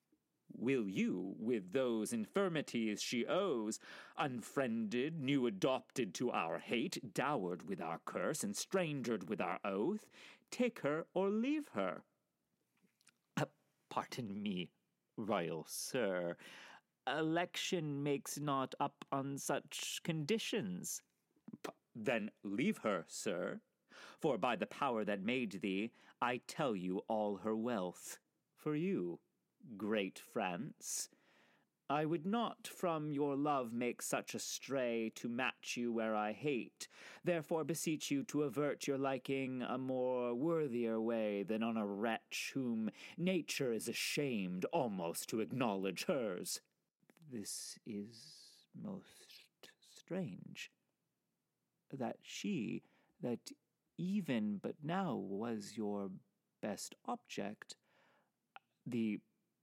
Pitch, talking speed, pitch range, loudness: 140 Hz, 115 wpm, 115-180 Hz, -40 LUFS